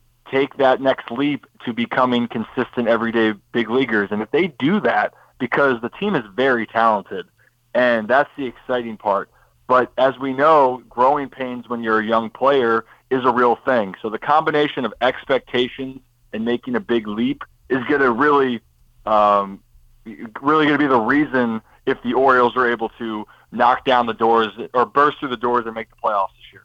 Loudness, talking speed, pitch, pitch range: -19 LUFS, 180 wpm, 120 Hz, 115-135 Hz